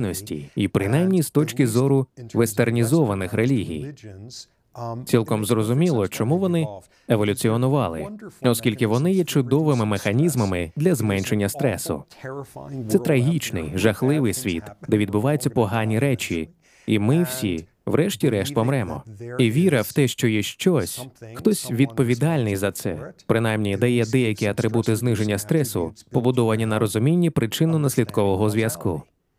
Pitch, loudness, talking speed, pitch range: 120 Hz, -22 LUFS, 115 wpm, 110-140 Hz